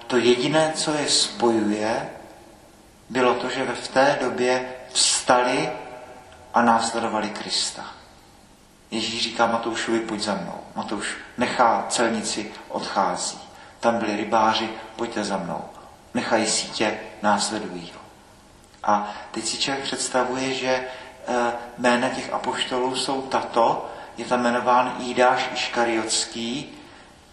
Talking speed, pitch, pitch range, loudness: 110 wpm, 120 Hz, 115-125 Hz, -23 LUFS